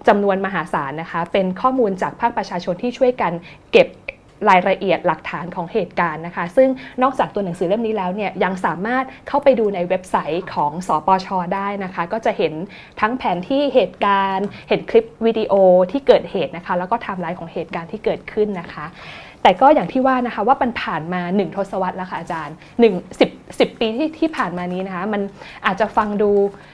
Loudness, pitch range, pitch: -19 LUFS, 180-230 Hz, 200 Hz